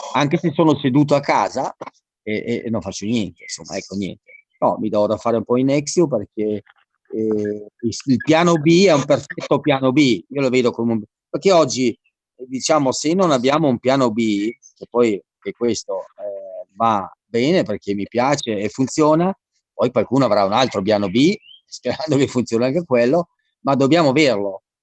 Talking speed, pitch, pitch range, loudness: 180 wpm, 125 Hz, 110-155 Hz, -18 LUFS